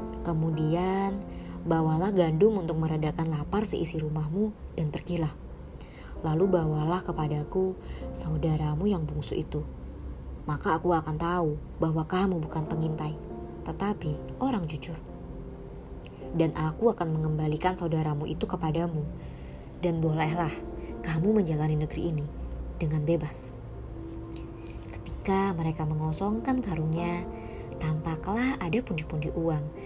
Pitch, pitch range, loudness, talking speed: 160 Hz, 150-175 Hz, -30 LUFS, 105 wpm